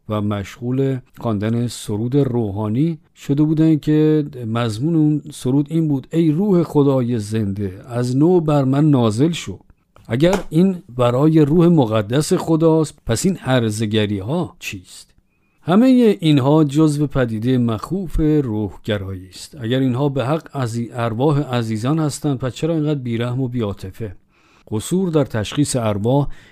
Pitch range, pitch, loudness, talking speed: 115-155 Hz, 135 Hz, -18 LUFS, 135 wpm